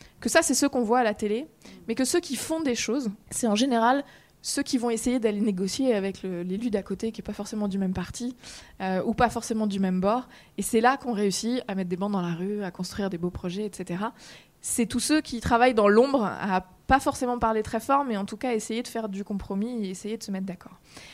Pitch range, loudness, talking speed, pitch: 195-245 Hz, -26 LUFS, 255 wpm, 220 Hz